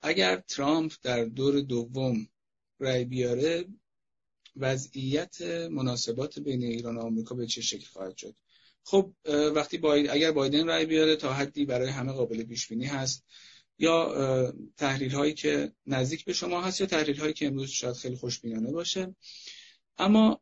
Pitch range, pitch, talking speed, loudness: 120-155 Hz, 135 Hz, 145 wpm, -29 LUFS